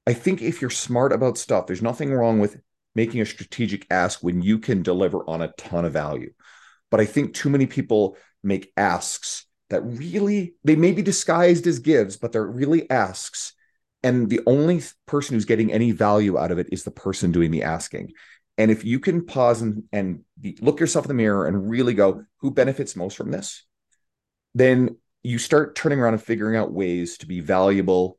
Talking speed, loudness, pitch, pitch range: 200 wpm, -22 LUFS, 115 Hz, 100-145 Hz